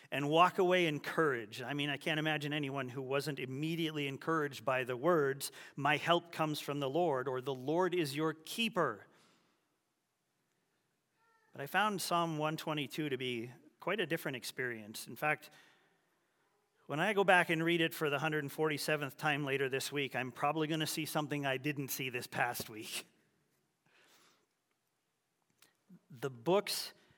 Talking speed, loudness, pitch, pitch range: 155 wpm, -35 LUFS, 150 Hz, 135-160 Hz